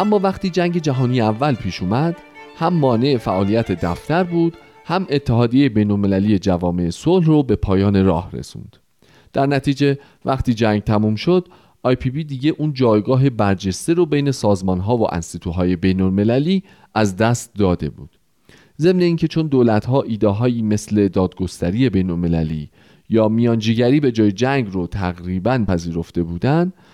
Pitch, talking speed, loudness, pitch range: 115 Hz, 140 wpm, -18 LUFS, 95-145 Hz